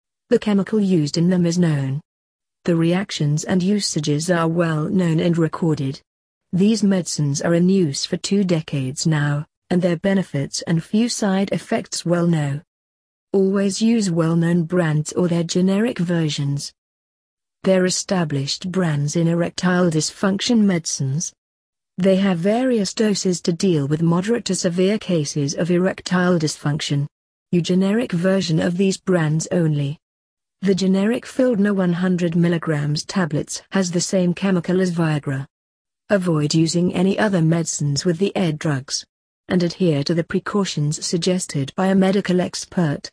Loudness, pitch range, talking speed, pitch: -20 LUFS, 155-190 Hz, 140 wpm, 175 Hz